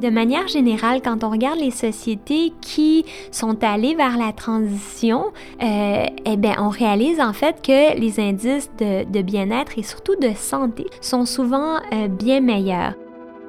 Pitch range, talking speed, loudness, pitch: 215-275 Hz, 160 wpm, -20 LUFS, 235 Hz